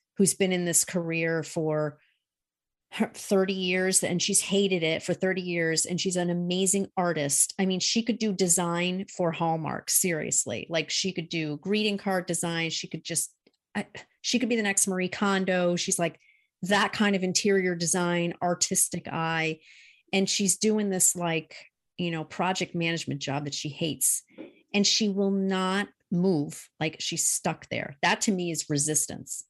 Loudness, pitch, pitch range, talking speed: -26 LUFS, 180 Hz, 165-195 Hz, 170 wpm